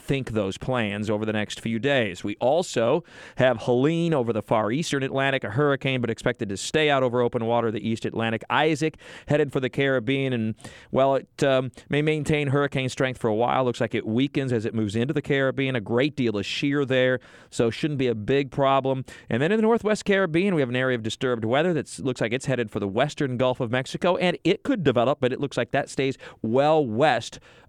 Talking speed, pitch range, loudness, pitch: 225 wpm, 120-145 Hz, -24 LUFS, 130 Hz